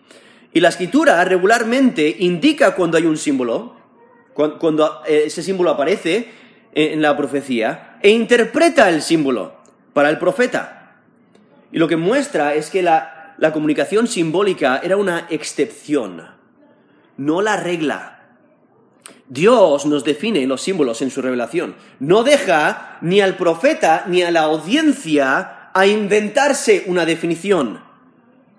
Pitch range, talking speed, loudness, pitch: 150-215 Hz, 125 wpm, -16 LUFS, 170 Hz